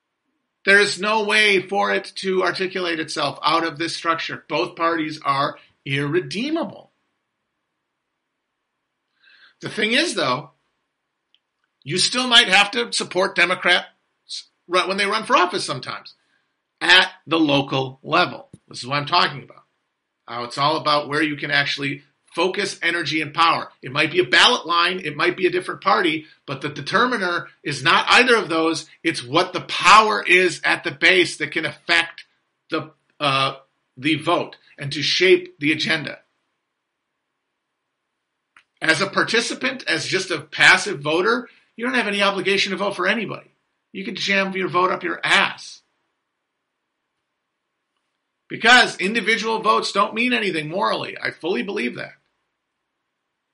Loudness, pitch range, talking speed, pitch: -19 LUFS, 155-205 Hz, 150 wpm, 180 Hz